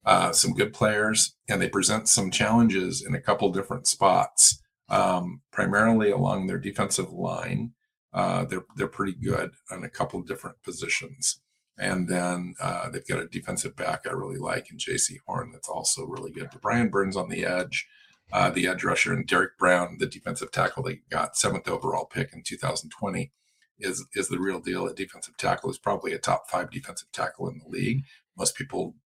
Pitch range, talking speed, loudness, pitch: 90-120 Hz, 185 wpm, -26 LUFS, 110 Hz